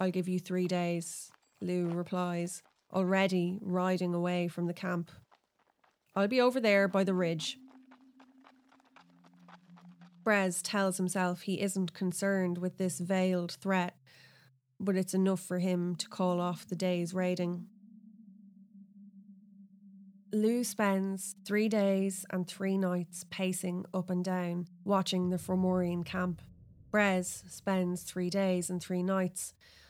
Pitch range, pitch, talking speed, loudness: 180-195 Hz, 185 Hz, 125 wpm, -32 LUFS